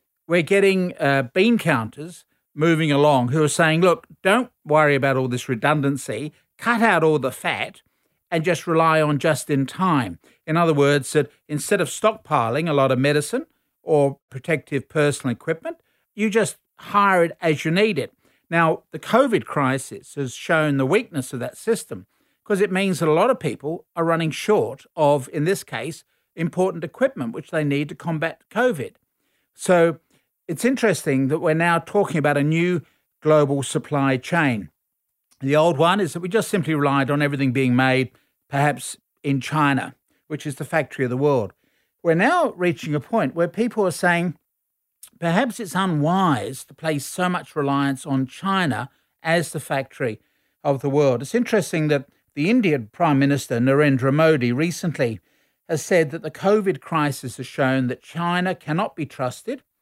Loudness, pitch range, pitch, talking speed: -21 LUFS, 140-175 Hz, 155 Hz, 170 wpm